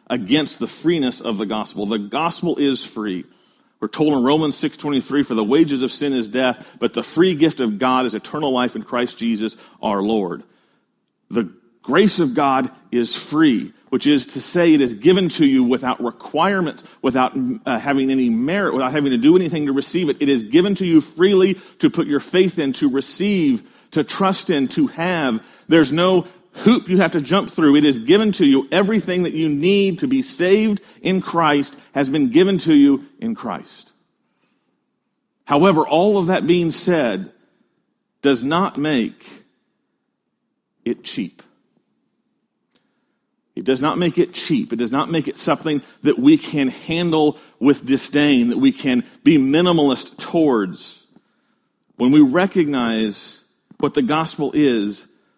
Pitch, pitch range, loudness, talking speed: 160 Hz, 135-195 Hz, -18 LUFS, 170 wpm